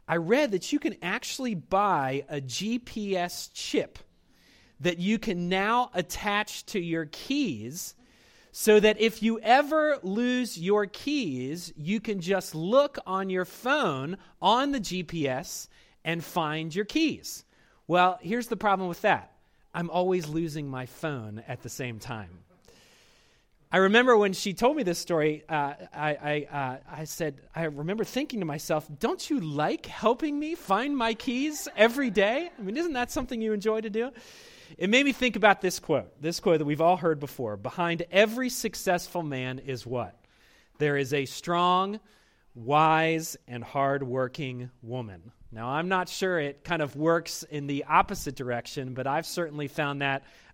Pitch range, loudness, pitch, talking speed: 145-215 Hz, -28 LUFS, 175 Hz, 165 wpm